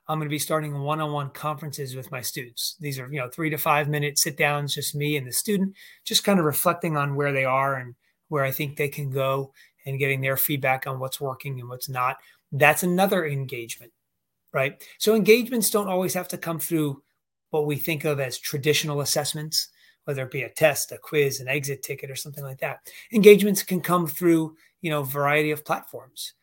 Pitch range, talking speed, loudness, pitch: 135-160 Hz, 210 wpm, -24 LUFS, 150 Hz